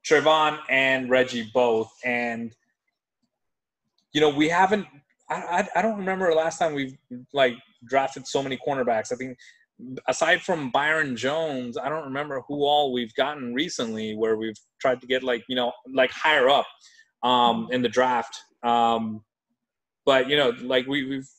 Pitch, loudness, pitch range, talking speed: 130 Hz, -24 LUFS, 120-155 Hz, 170 wpm